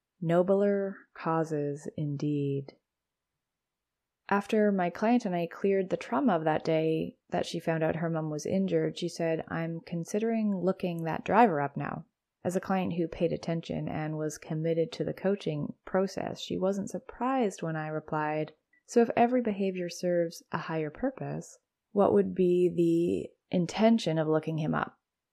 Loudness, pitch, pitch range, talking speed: -30 LUFS, 175 Hz, 160-195 Hz, 160 wpm